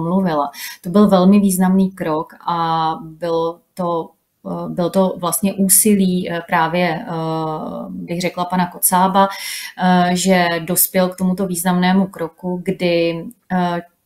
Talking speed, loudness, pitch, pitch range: 105 wpm, -17 LUFS, 180 Hz, 170-190 Hz